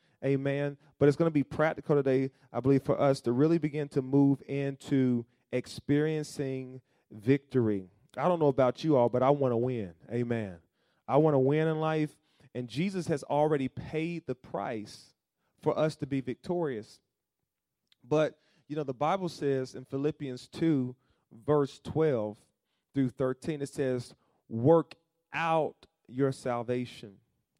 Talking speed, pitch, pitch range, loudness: 150 wpm, 140 Hz, 125-155 Hz, -30 LUFS